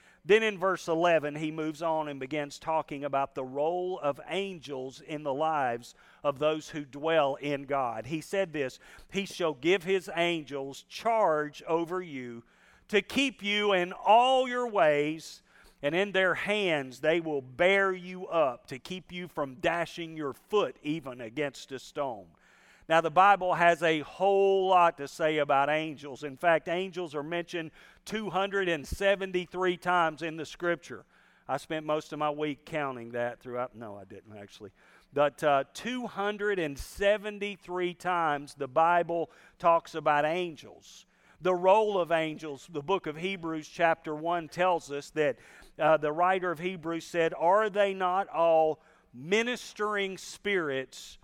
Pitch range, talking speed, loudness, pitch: 145-185 Hz, 150 wpm, -29 LUFS, 165 Hz